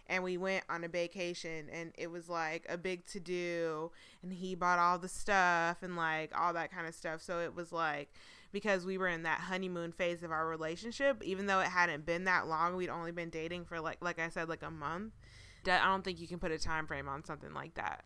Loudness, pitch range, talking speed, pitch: -36 LUFS, 165-185 Hz, 245 wpm, 175 Hz